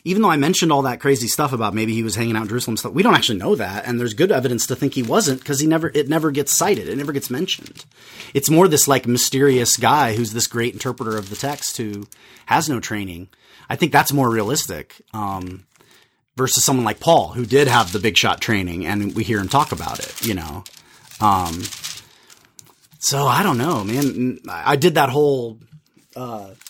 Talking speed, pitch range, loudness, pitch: 215 wpm, 110-145 Hz, -18 LUFS, 125 Hz